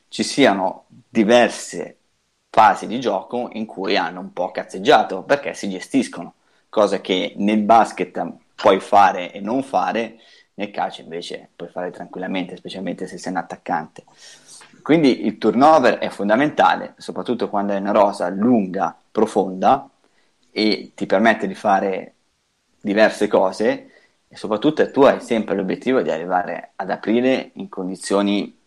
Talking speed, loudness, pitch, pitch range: 140 wpm, -19 LUFS, 105 Hz, 100-120 Hz